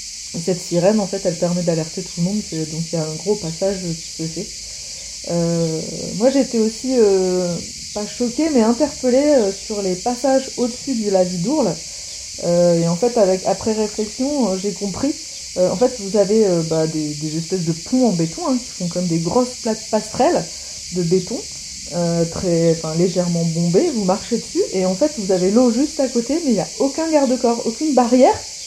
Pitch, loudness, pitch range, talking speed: 195 Hz, -19 LUFS, 170-245 Hz, 200 wpm